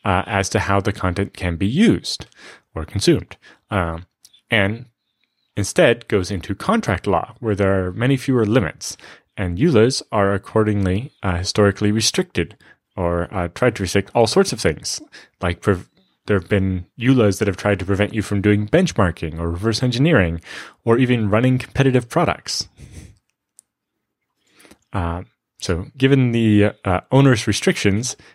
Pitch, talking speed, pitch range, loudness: 105 Hz, 150 wpm, 95-120 Hz, -19 LUFS